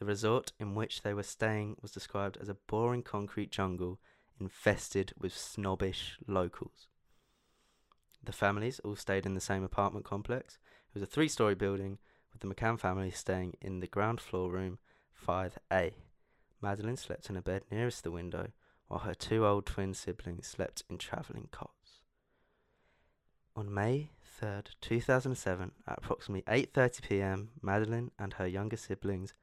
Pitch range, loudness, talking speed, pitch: 95-110 Hz, -36 LUFS, 150 wpm, 100 Hz